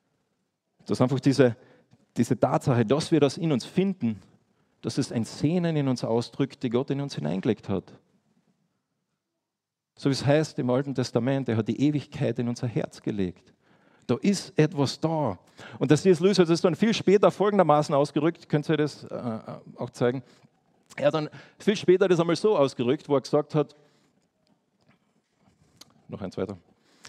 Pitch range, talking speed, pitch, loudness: 125-160 Hz, 175 wpm, 140 Hz, -25 LUFS